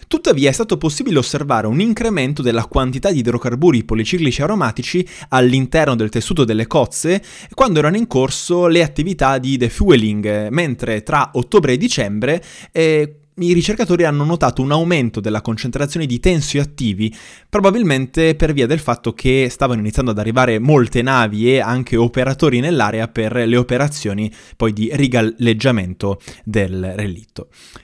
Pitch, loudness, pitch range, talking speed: 130 Hz, -16 LUFS, 115-160 Hz, 140 wpm